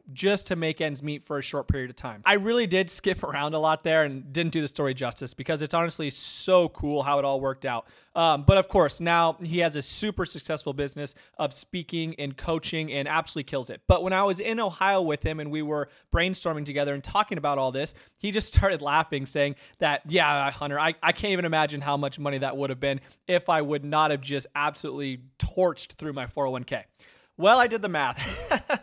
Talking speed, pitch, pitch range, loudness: 225 wpm, 150 Hz, 140-170 Hz, -26 LUFS